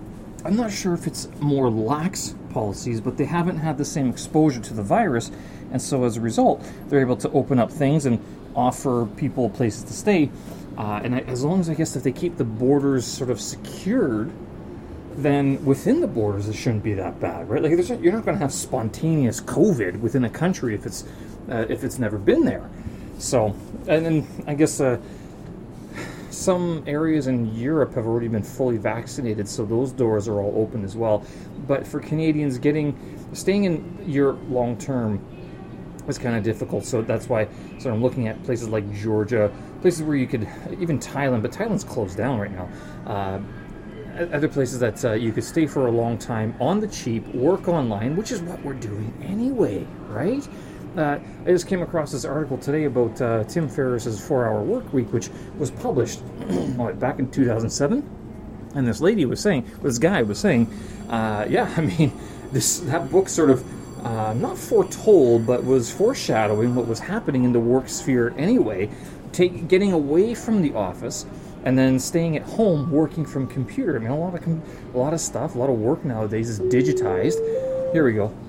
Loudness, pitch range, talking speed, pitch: -23 LUFS, 115-155 Hz, 190 wpm, 130 Hz